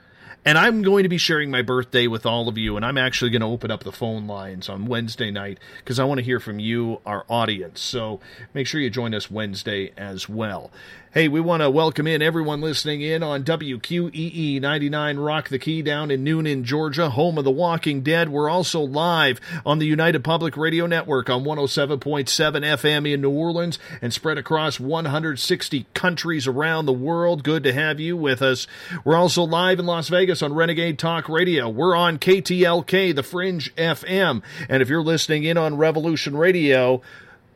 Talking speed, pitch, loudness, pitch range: 190 wpm, 150 Hz, -21 LUFS, 130-165 Hz